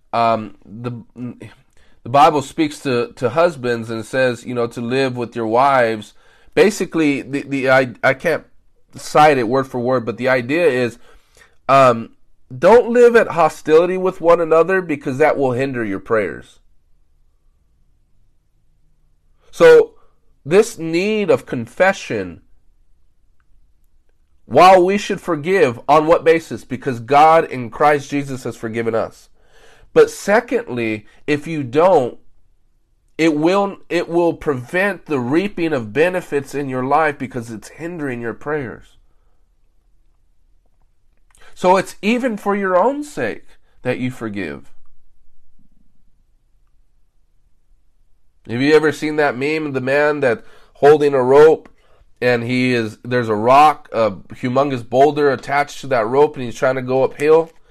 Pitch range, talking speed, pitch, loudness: 115-160 Hz, 135 wpm, 135 Hz, -16 LUFS